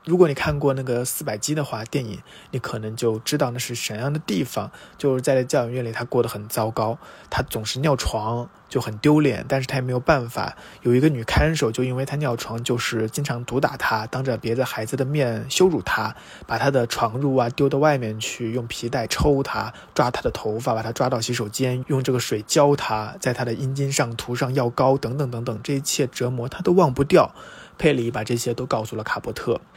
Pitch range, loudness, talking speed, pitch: 115-140 Hz, -23 LUFS, 320 characters per minute, 125 Hz